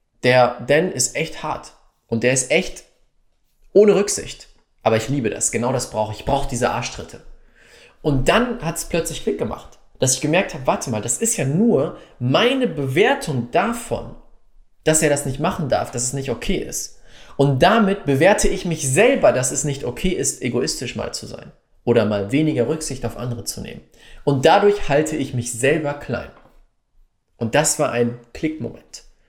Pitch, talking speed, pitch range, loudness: 140 Hz, 180 wpm, 120-170 Hz, -19 LUFS